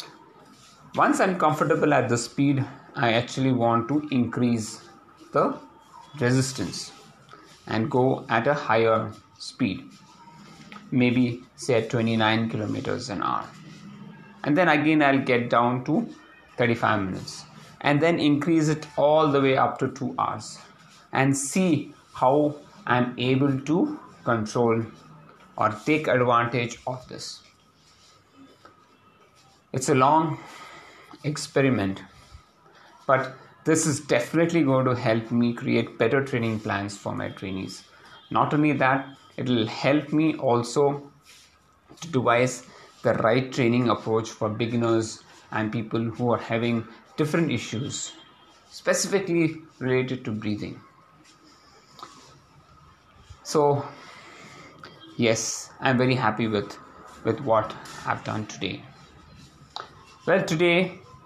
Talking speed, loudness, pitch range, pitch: 115 wpm, -24 LUFS, 115-150 Hz, 125 Hz